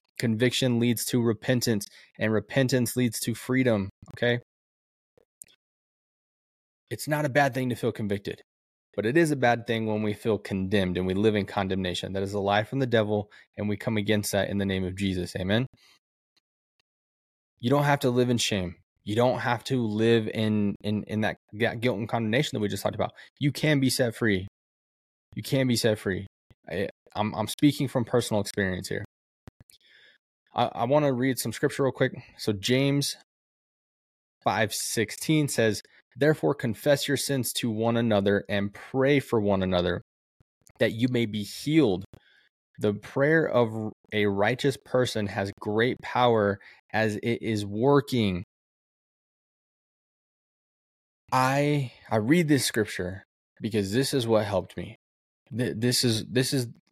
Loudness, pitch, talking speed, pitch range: -26 LUFS, 115 Hz, 160 wpm, 100-130 Hz